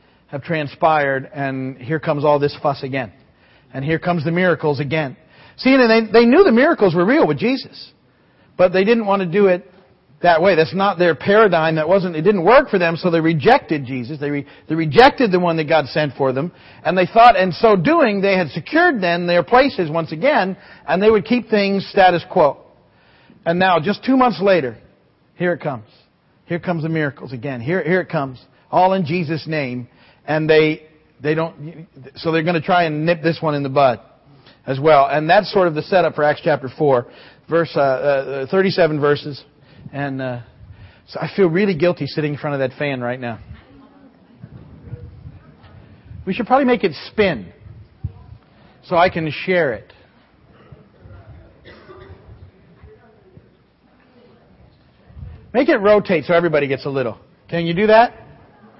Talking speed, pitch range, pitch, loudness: 180 wpm, 140-185 Hz, 160 Hz, -17 LUFS